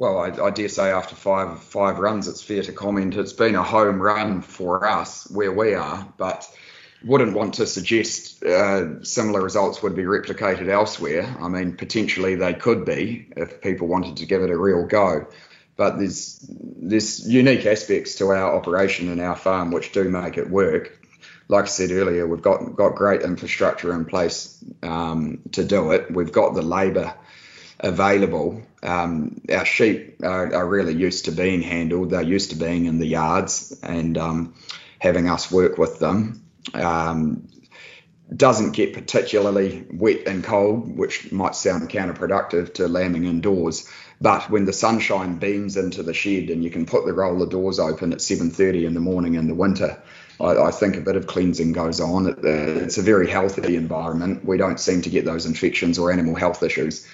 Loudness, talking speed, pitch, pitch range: -21 LUFS, 180 wpm, 90 Hz, 85-95 Hz